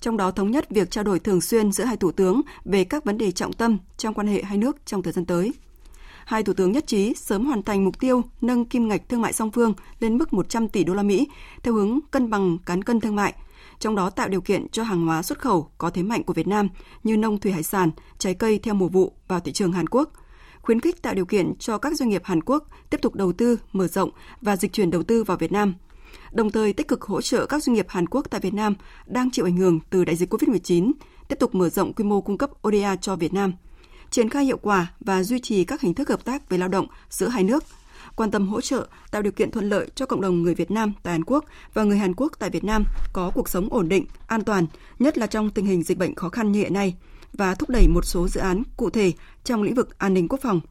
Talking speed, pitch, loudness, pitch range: 270 wpm, 205 Hz, -23 LUFS, 185-235 Hz